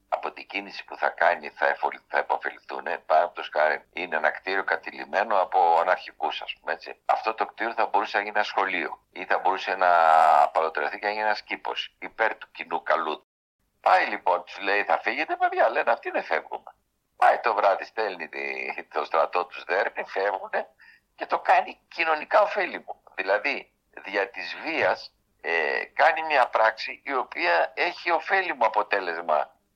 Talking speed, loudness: 165 wpm, -25 LUFS